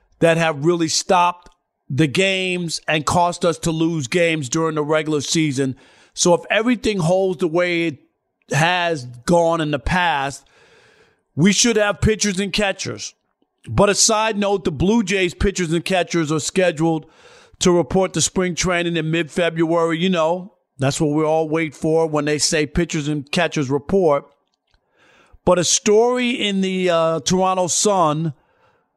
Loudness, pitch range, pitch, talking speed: -18 LUFS, 160-185 Hz, 170 Hz, 155 wpm